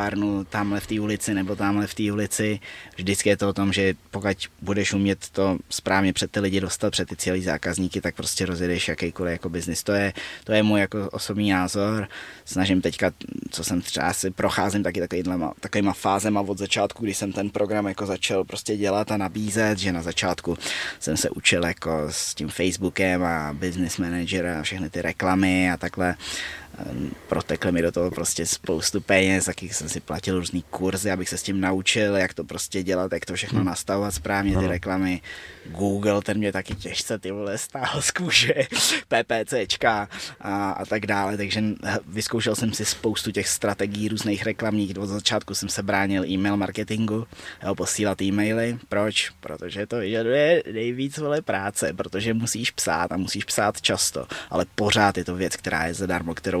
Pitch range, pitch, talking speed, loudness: 90-105 Hz, 95 Hz, 180 wpm, -24 LUFS